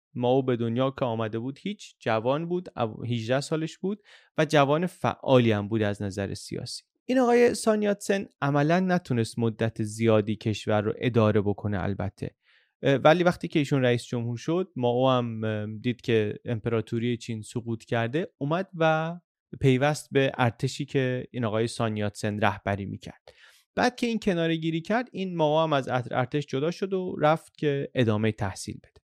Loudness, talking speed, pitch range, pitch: -27 LUFS, 165 wpm, 115-160 Hz, 130 Hz